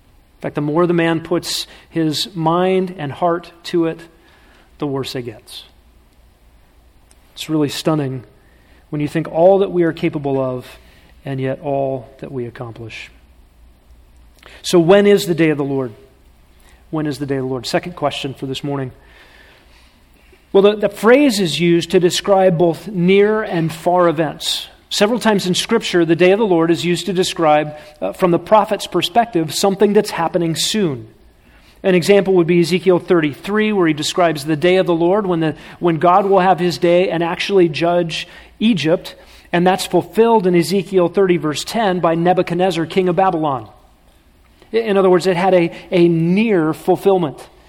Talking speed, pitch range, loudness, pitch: 175 wpm, 140-185 Hz, -16 LUFS, 170 Hz